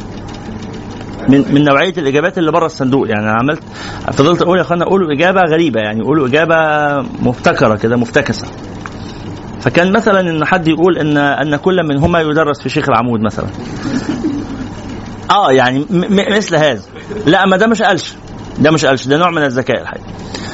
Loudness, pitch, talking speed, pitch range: -12 LUFS, 140 Hz, 165 wpm, 110-170 Hz